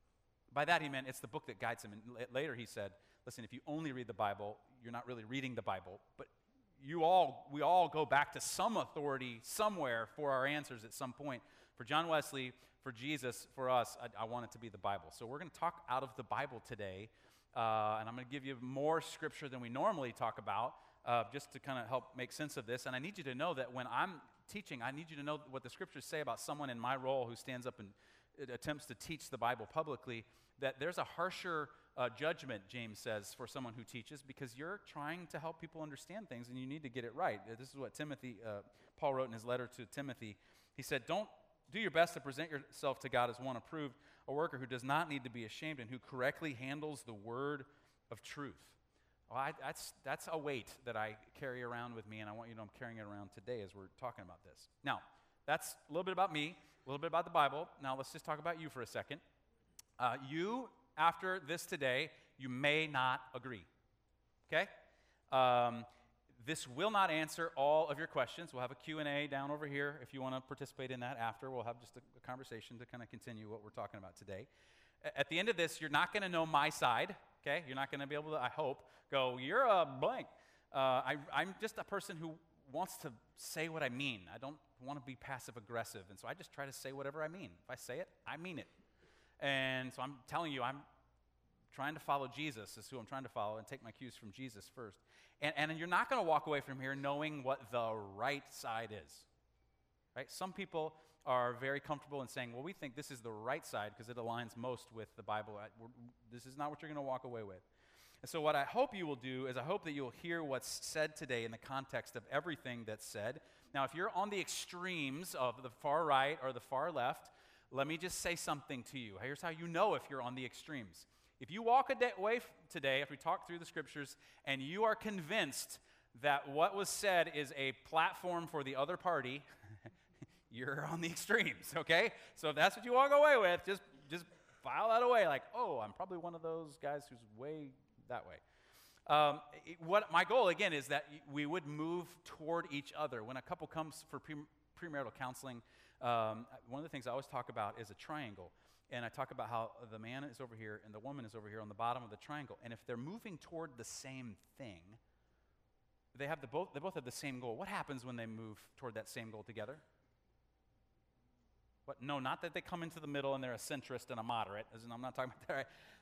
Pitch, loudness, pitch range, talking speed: 135 Hz, -41 LUFS, 120-155 Hz, 235 wpm